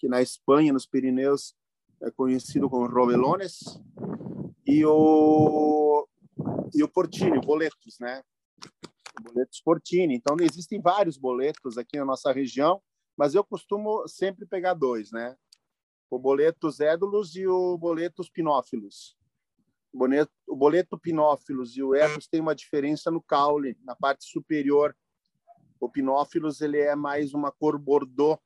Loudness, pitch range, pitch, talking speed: -25 LUFS, 135-170 Hz, 150 Hz, 140 wpm